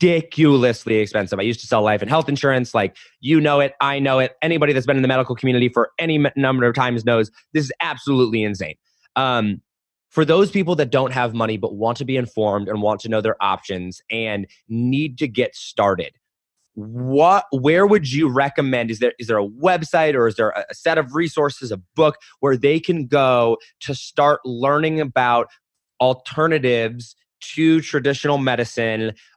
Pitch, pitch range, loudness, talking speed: 130 Hz, 115-150 Hz, -19 LUFS, 185 wpm